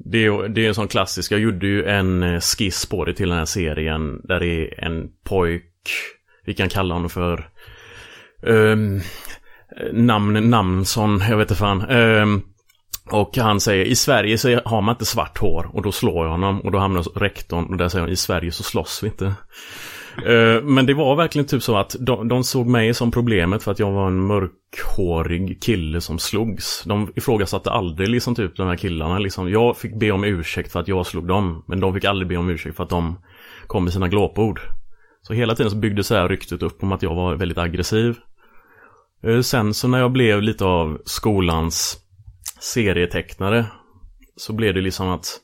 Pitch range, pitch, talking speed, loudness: 90-110 Hz, 100 Hz, 200 wpm, -20 LUFS